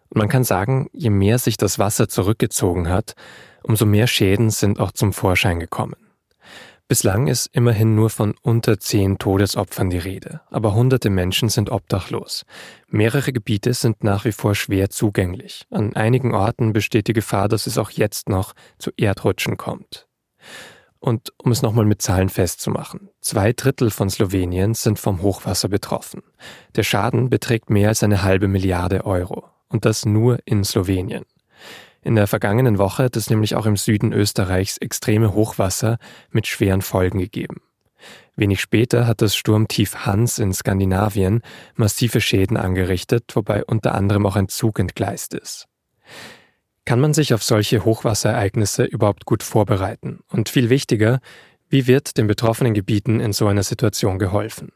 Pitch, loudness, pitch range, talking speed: 110 Hz, -19 LUFS, 100-120 Hz, 155 wpm